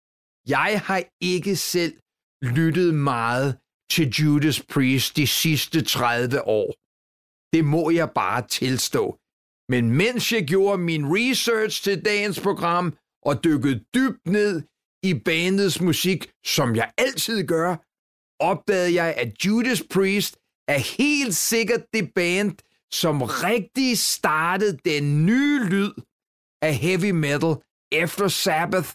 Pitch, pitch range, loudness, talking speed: 175 Hz, 150-200 Hz, -22 LUFS, 120 wpm